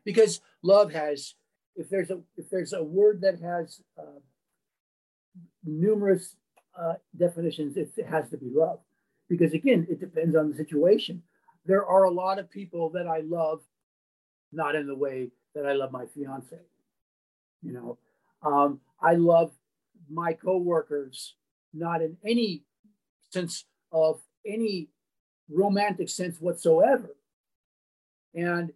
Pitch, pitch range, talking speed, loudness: 170 Hz, 150-190 Hz, 135 wpm, -27 LUFS